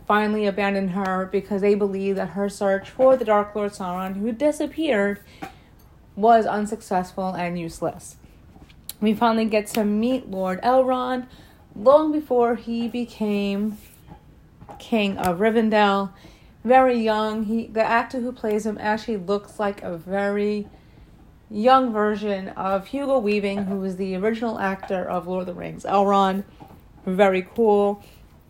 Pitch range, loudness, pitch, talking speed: 195-230 Hz, -22 LUFS, 205 Hz, 135 wpm